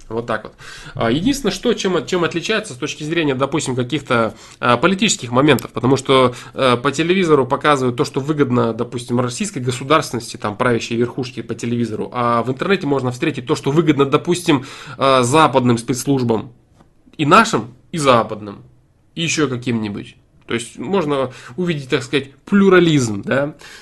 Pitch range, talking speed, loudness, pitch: 120-155 Hz, 145 wpm, -17 LUFS, 135 Hz